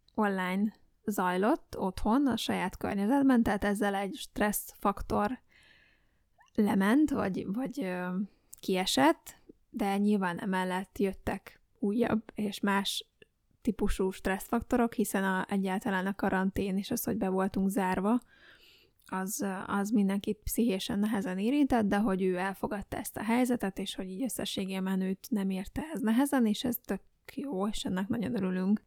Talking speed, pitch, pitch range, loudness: 135 wpm, 205 Hz, 190-230 Hz, -31 LUFS